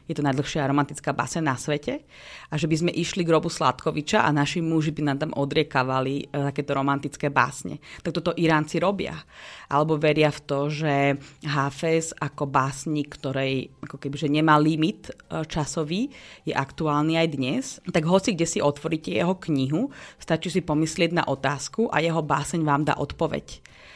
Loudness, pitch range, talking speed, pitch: -25 LUFS, 140-165 Hz, 165 wpm, 150 Hz